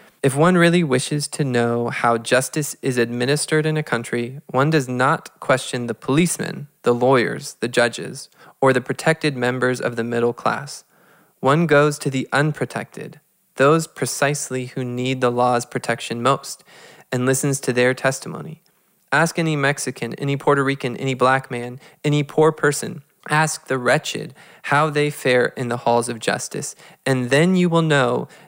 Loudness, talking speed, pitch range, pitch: -20 LUFS, 160 wpm, 125-155 Hz, 135 Hz